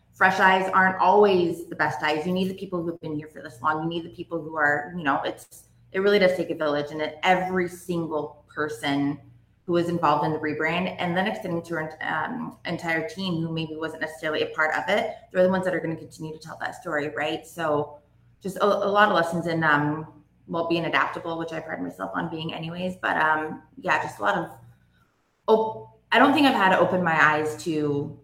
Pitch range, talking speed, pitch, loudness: 150-180 Hz, 235 wpm, 160 Hz, -24 LUFS